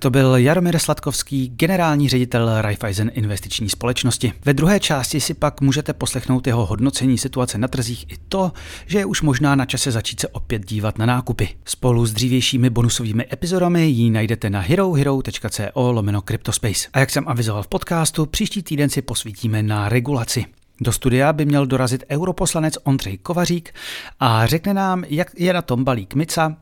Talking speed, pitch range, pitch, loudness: 170 wpm, 115-150 Hz, 130 Hz, -19 LUFS